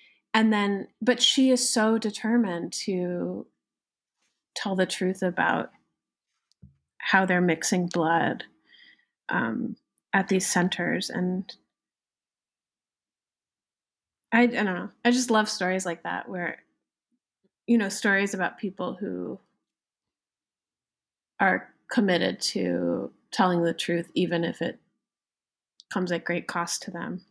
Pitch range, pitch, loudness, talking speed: 175-220 Hz, 190 Hz, -26 LUFS, 115 wpm